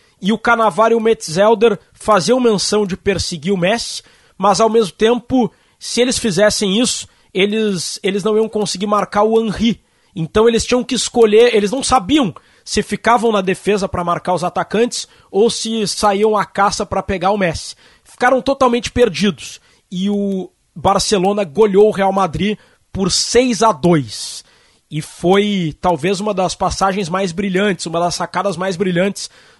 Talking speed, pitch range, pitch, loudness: 160 wpm, 190-225 Hz, 205 Hz, -15 LUFS